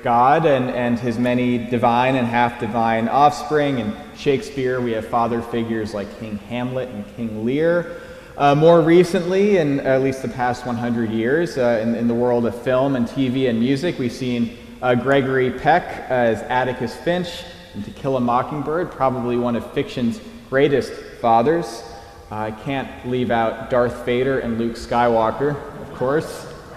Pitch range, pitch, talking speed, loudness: 115-140 Hz, 125 Hz, 165 wpm, -20 LUFS